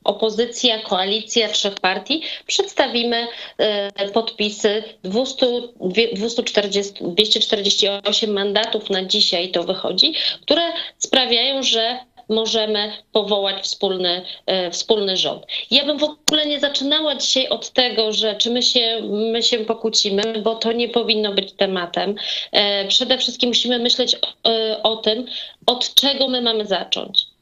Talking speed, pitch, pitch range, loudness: 130 wpm, 225 Hz, 205-245 Hz, -18 LUFS